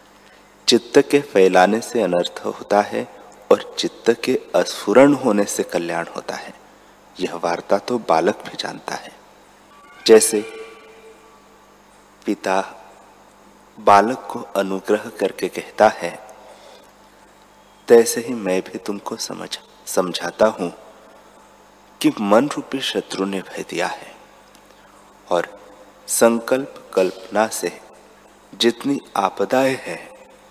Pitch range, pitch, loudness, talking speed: 95-125 Hz, 110 Hz, -19 LUFS, 105 wpm